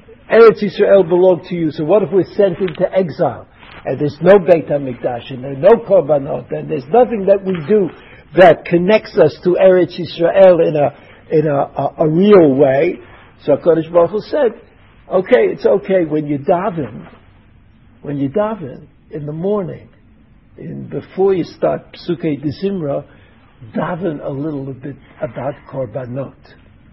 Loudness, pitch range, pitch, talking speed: -14 LUFS, 140-195 Hz, 165 Hz, 155 wpm